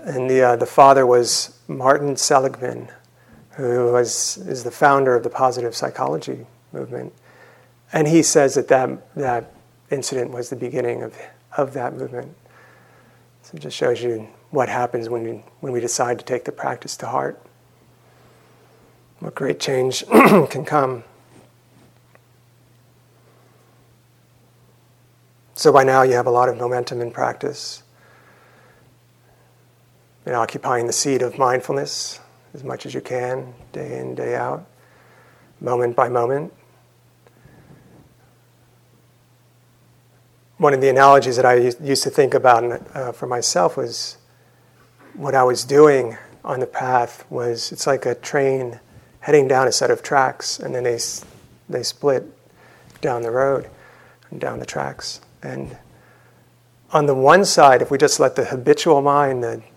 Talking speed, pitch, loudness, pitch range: 140 wpm, 125 Hz, -18 LUFS, 120-135 Hz